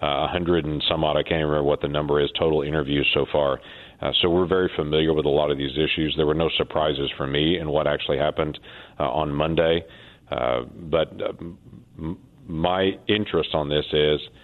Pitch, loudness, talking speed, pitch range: 80 Hz, -23 LUFS, 210 wpm, 75-85 Hz